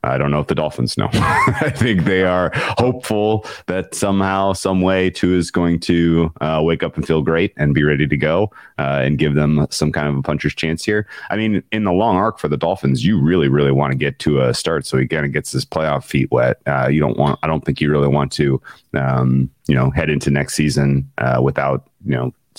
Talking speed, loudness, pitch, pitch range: 235 wpm, -17 LUFS, 75 Hz, 70-90 Hz